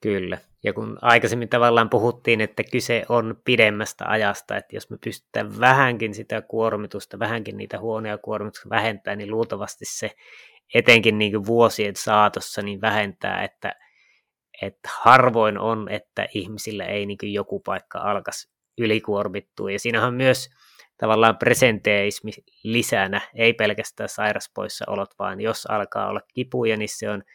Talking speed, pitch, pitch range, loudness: 145 wpm, 110 Hz, 105-115 Hz, -22 LUFS